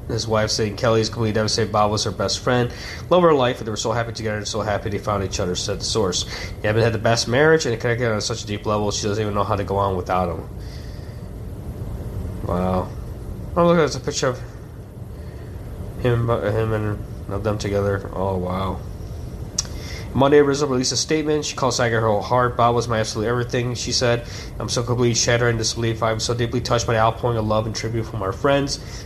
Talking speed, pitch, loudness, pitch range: 225 wpm, 110 Hz, -21 LUFS, 100-120 Hz